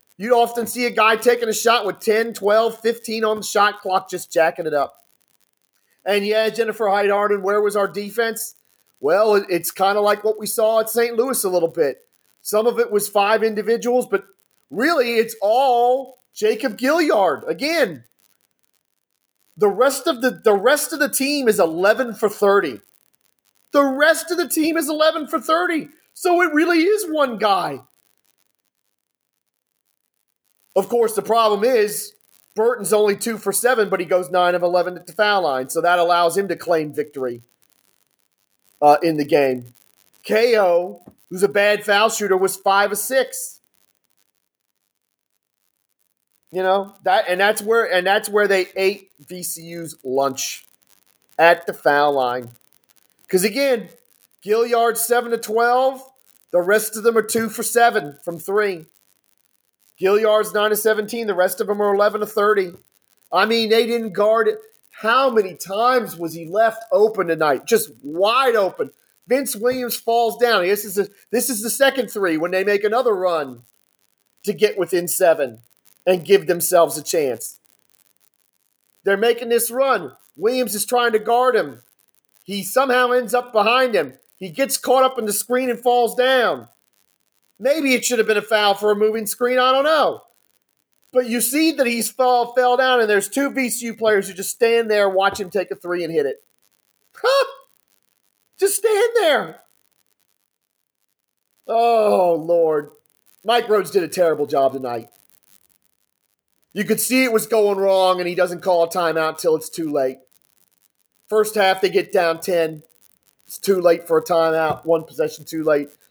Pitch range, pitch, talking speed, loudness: 180-240 Hz, 210 Hz, 165 wpm, -19 LUFS